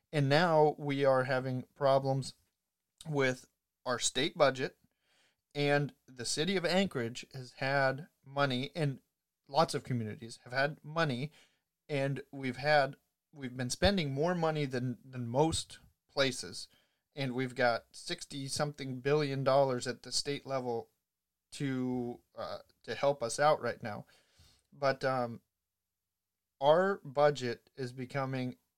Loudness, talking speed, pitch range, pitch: -33 LUFS, 130 wpm, 125-145 Hz, 135 Hz